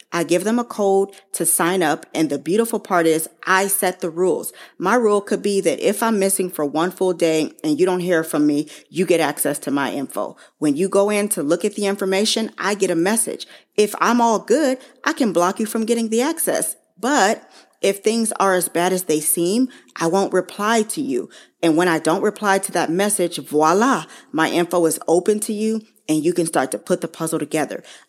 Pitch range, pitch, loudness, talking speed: 165-215 Hz, 185 Hz, -19 LUFS, 225 wpm